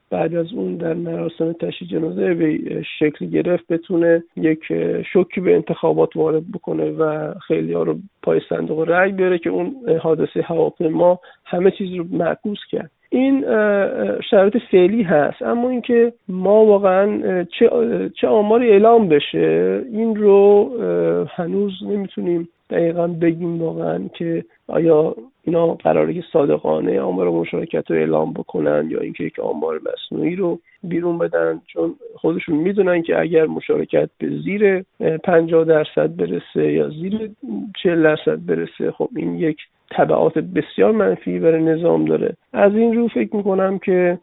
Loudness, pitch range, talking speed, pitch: -18 LUFS, 160-210 Hz, 140 wpm, 175 Hz